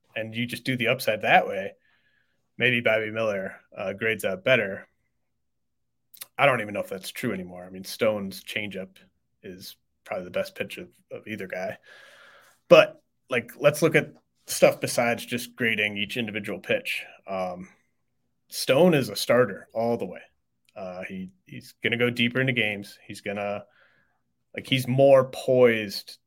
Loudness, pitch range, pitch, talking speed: -25 LUFS, 100-125 Hz, 110 Hz, 165 wpm